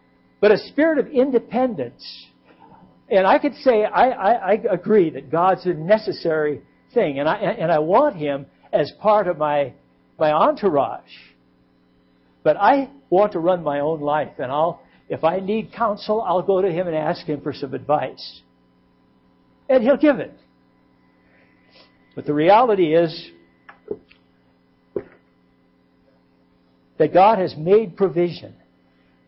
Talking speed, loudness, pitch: 135 wpm, -19 LUFS, 155 Hz